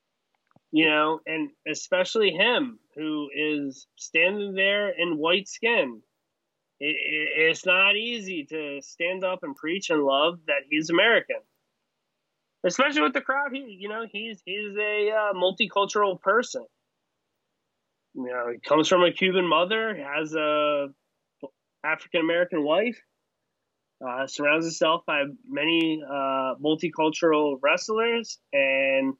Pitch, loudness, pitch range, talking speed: 175 Hz, -24 LUFS, 150-210 Hz, 125 wpm